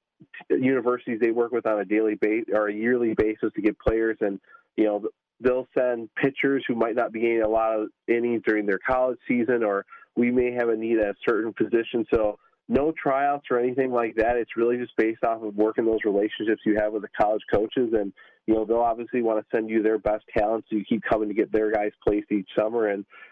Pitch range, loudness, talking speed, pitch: 110-120 Hz, -25 LUFS, 230 wpm, 115 Hz